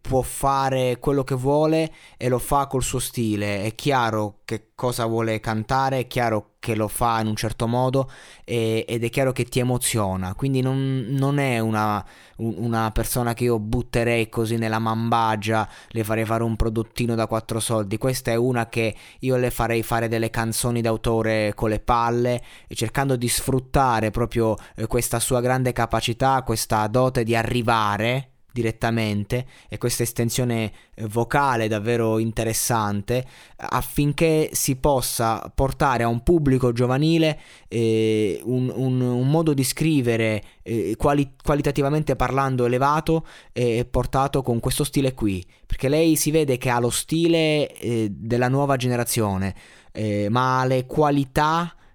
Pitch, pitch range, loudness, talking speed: 120 Hz, 110-130 Hz, -22 LUFS, 150 wpm